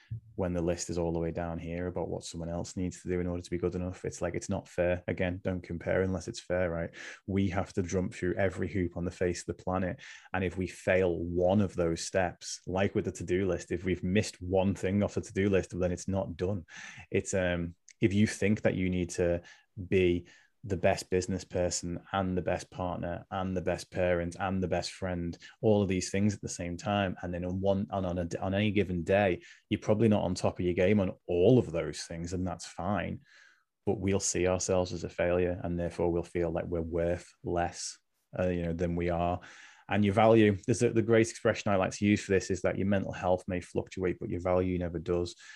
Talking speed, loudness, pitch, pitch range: 240 wpm, -31 LUFS, 90 Hz, 85-95 Hz